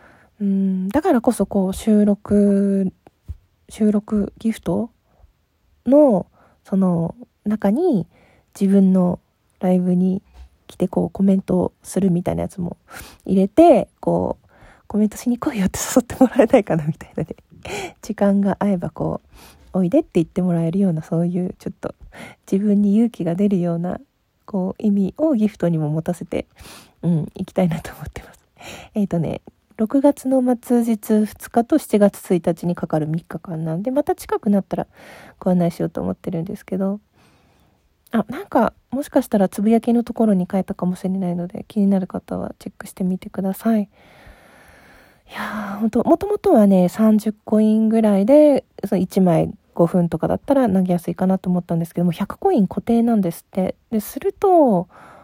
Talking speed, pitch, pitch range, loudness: 320 characters per minute, 195 Hz, 180-225 Hz, -19 LUFS